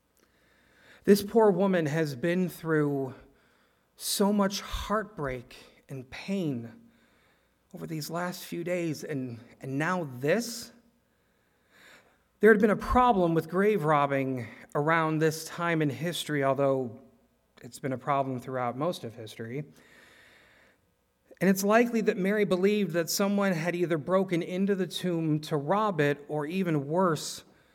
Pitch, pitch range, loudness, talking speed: 160 Hz, 135-190 Hz, -28 LUFS, 135 wpm